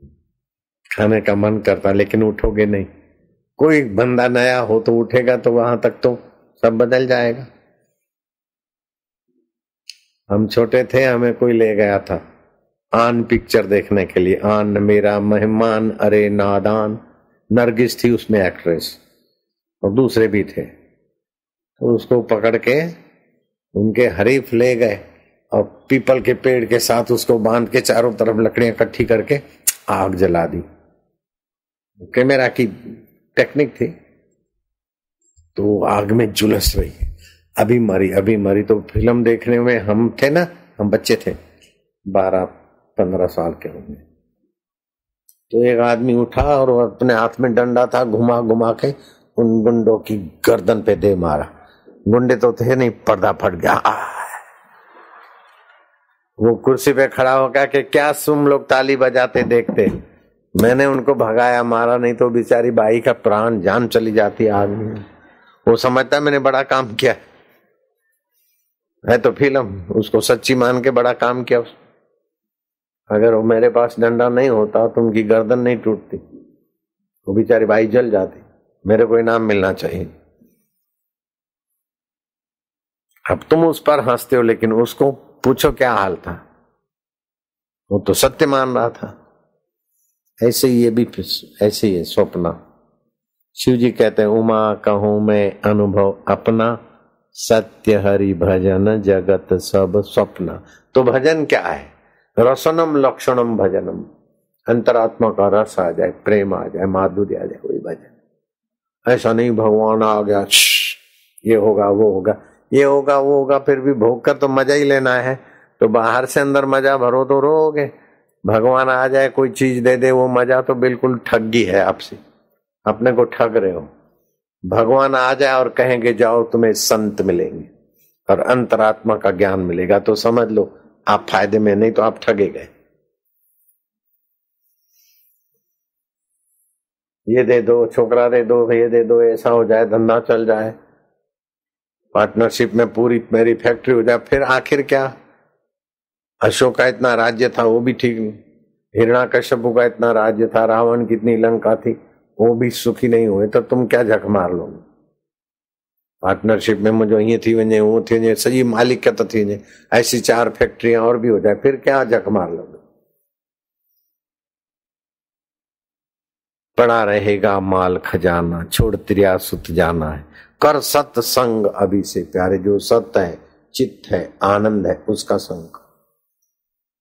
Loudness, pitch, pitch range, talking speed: -16 LUFS, 115 Hz, 105-125 Hz, 145 wpm